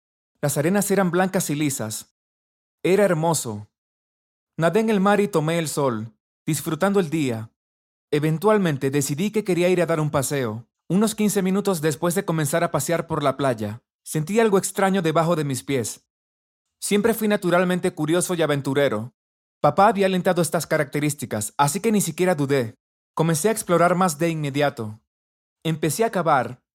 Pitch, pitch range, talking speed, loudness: 160 Hz, 130-185 Hz, 160 wpm, -22 LUFS